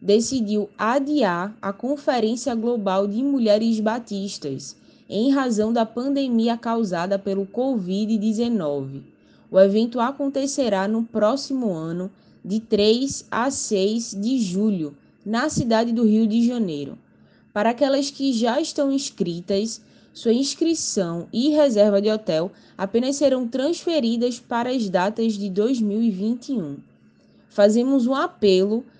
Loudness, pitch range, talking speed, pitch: -22 LUFS, 200-255 Hz, 115 wpm, 225 Hz